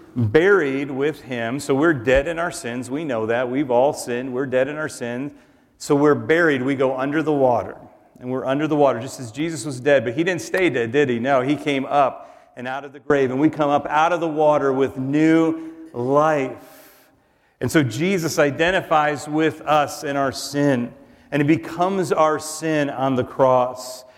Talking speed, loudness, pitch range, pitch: 205 wpm, -20 LUFS, 130-155 Hz, 145 Hz